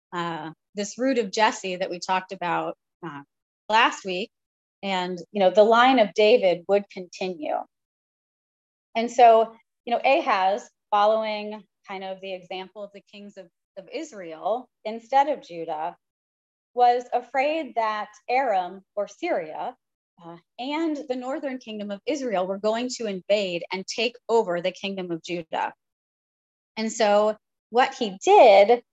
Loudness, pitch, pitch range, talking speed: -23 LUFS, 205 Hz, 185-240 Hz, 145 wpm